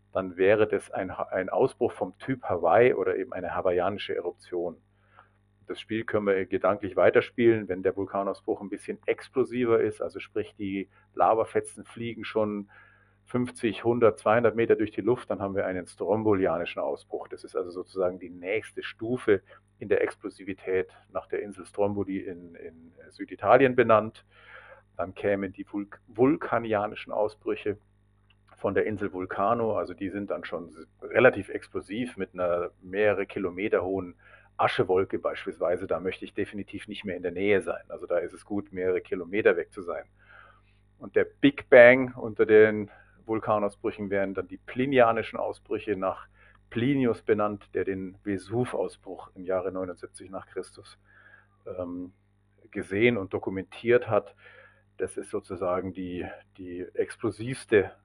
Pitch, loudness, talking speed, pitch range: 100 Hz, -27 LUFS, 145 wpm, 95-120 Hz